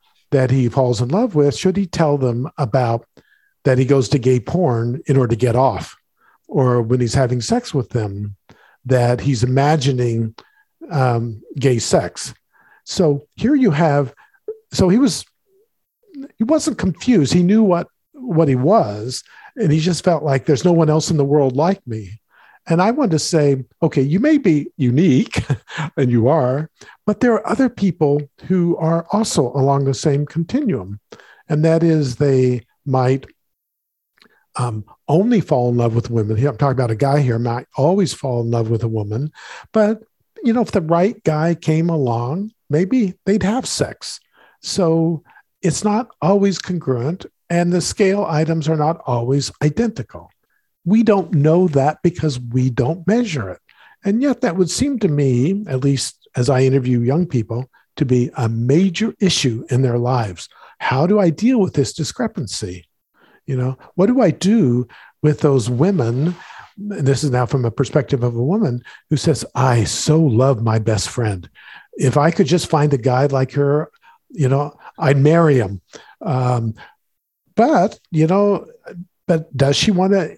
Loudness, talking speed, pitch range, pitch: -17 LUFS, 170 wpm, 130-180 Hz, 150 Hz